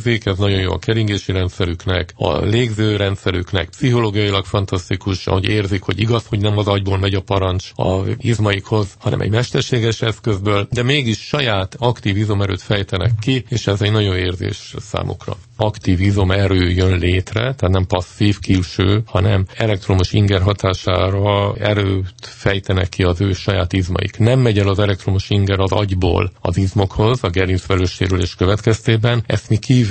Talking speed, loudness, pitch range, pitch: 155 wpm, -17 LUFS, 95-110 Hz, 100 Hz